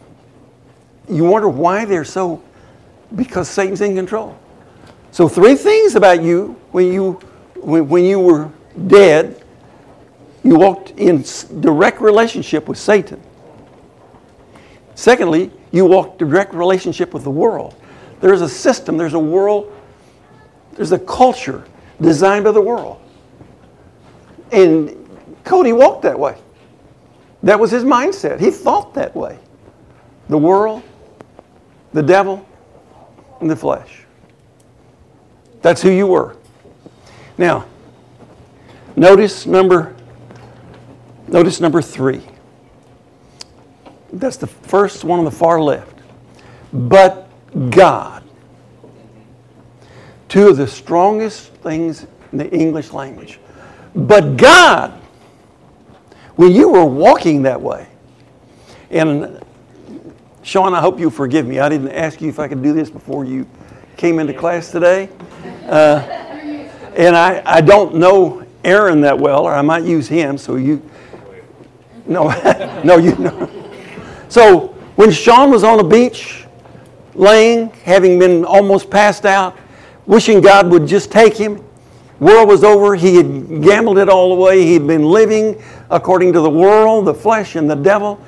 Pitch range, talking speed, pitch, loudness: 155-205 Hz, 130 wpm, 180 Hz, -11 LUFS